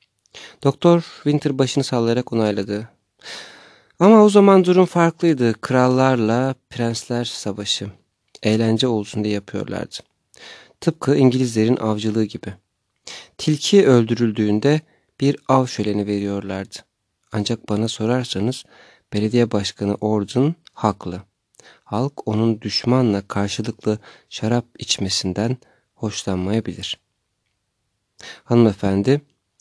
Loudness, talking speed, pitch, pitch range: -19 LUFS, 85 wpm, 115 Hz, 105-130 Hz